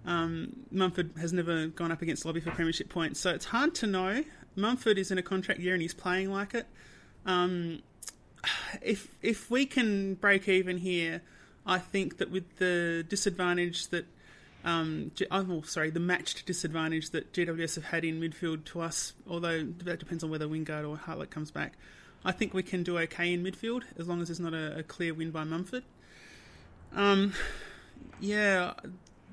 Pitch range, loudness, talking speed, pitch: 165-195 Hz, -32 LUFS, 180 wpm, 175 Hz